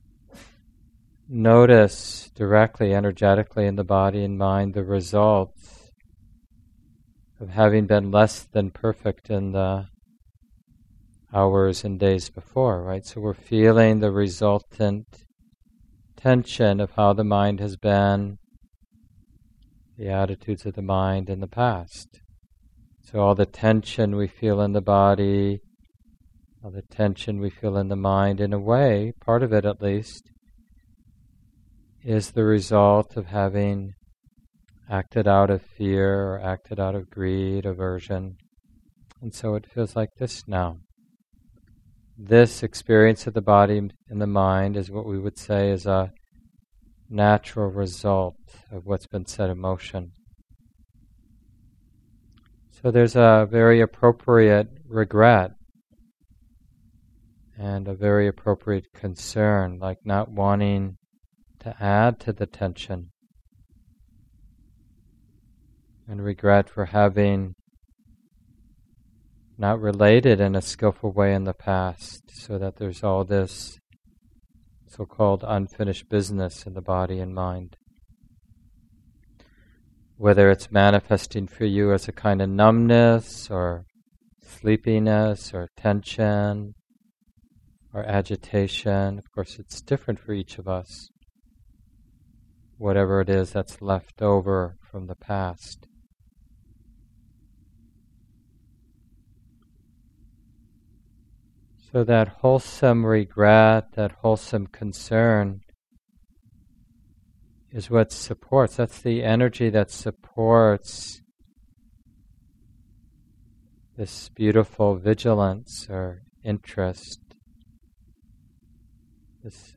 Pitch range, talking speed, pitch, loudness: 95-110 Hz, 105 wpm, 105 Hz, -22 LUFS